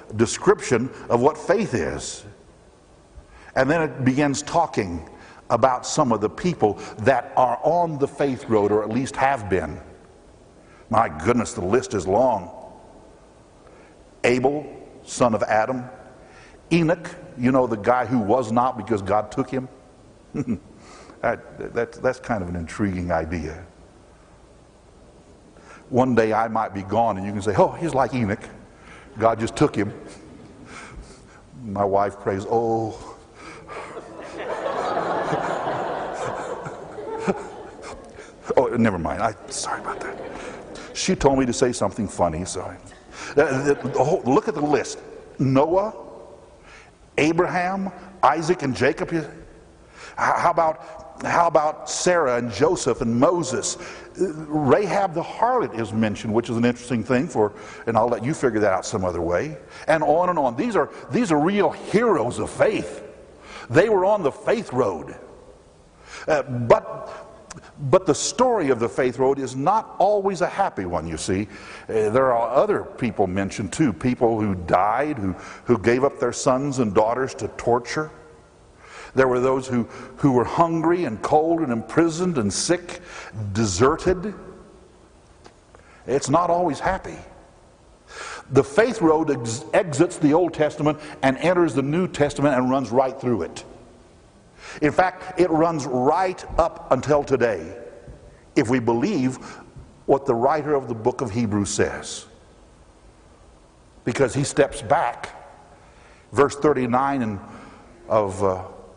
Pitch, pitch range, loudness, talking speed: 130 Hz, 110-160 Hz, -22 LUFS, 140 wpm